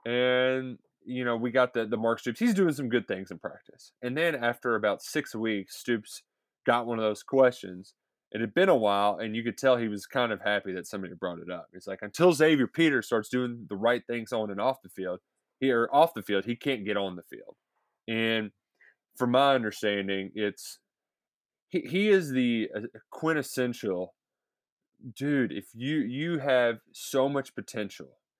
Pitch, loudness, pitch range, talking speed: 120 Hz, -28 LUFS, 105-130 Hz, 190 wpm